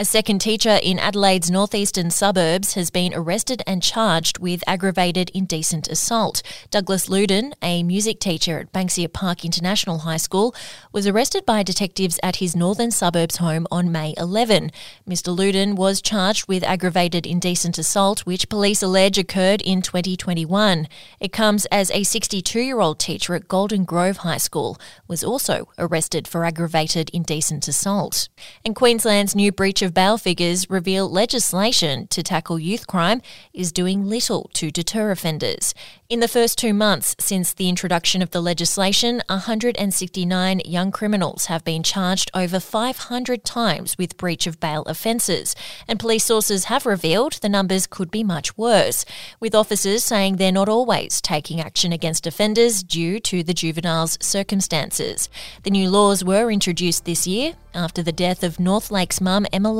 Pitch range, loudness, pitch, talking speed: 175-205 Hz, -20 LUFS, 190 Hz, 155 wpm